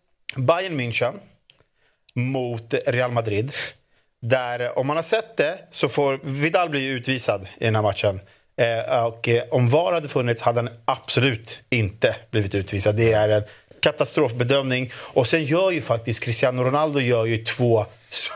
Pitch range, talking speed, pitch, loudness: 115-135 Hz, 150 wpm, 120 Hz, -22 LUFS